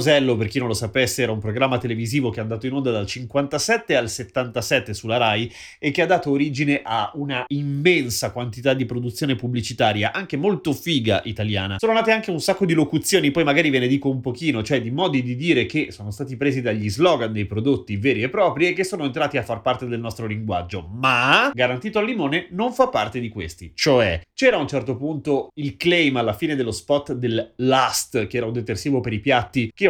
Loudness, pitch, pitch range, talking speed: -21 LUFS, 130 Hz, 115-145 Hz, 215 wpm